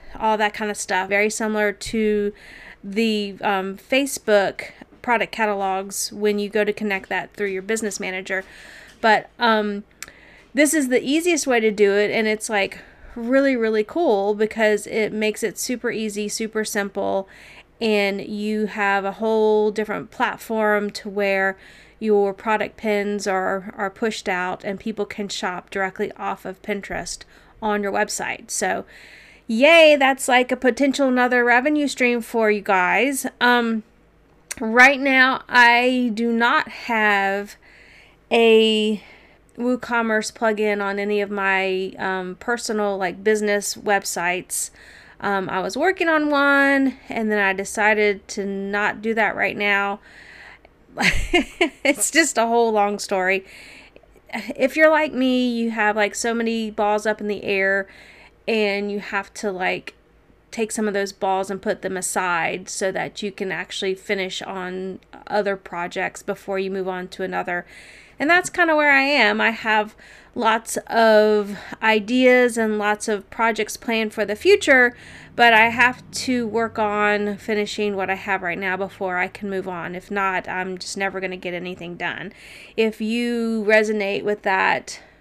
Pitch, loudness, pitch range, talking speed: 210 Hz, -20 LUFS, 200-230 Hz, 155 wpm